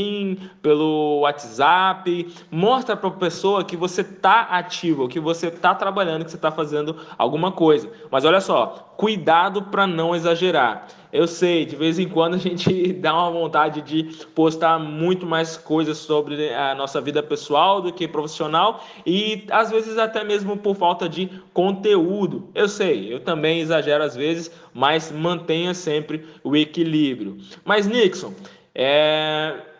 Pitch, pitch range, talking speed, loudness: 165 Hz, 155-185 Hz, 150 wpm, -20 LUFS